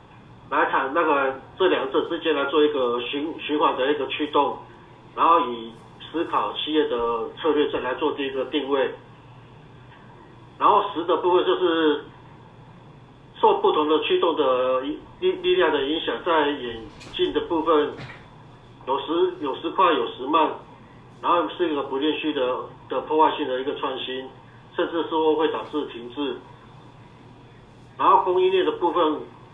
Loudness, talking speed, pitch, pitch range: -23 LUFS, 220 characters per minute, 145 Hz, 125-170 Hz